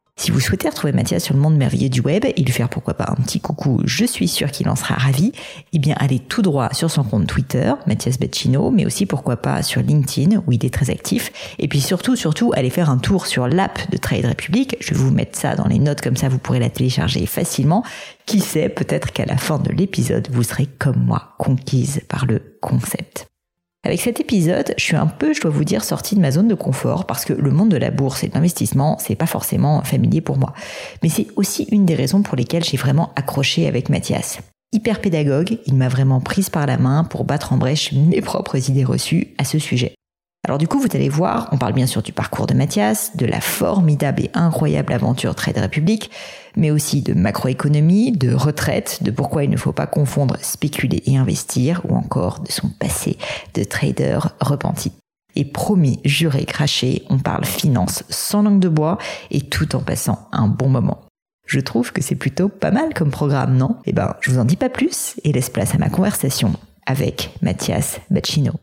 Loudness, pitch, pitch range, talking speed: -18 LUFS, 150 Hz, 135-180 Hz, 220 wpm